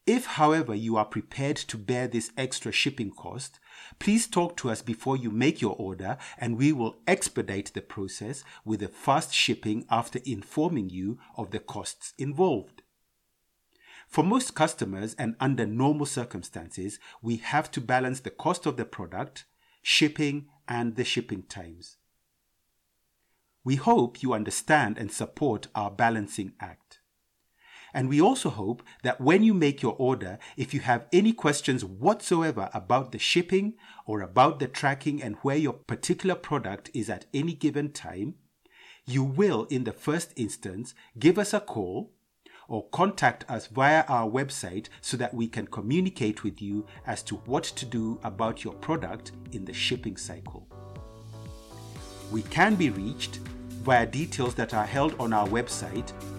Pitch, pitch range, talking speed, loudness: 120 Hz, 110-145 Hz, 155 wpm, -28 LUFS